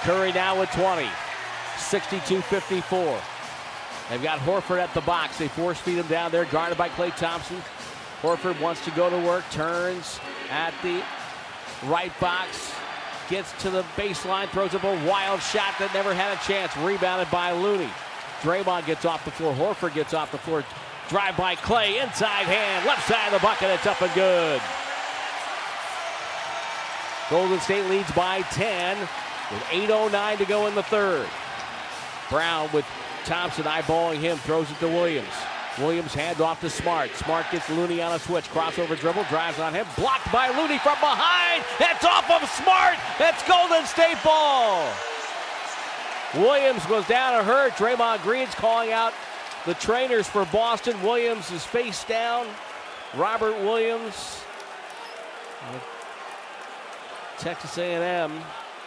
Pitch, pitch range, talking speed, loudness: 185 Hz, 170-225 Hz, 145 wpm, -24 LUFS